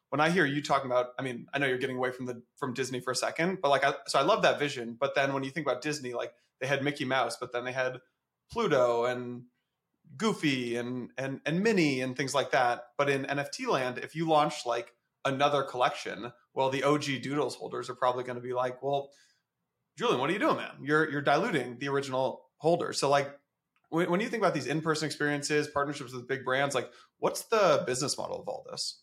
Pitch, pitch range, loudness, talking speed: 140 Hz, 125-145 Hz, -30 LUFS, 230 wpm